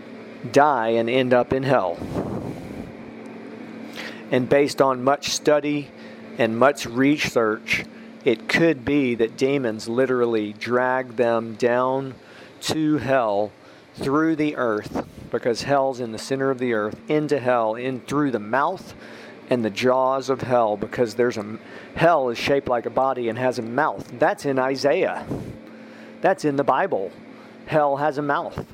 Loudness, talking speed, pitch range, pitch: -22 LUFS, 150 wpm, 120-140 Hz, 130 Hz